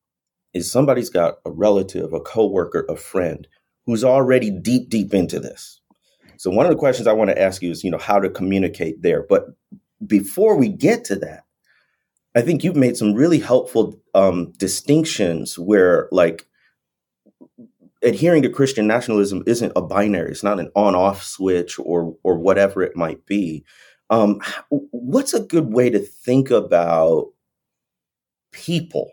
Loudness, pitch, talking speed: -18 LUFS, 120 Hz, 155 wpm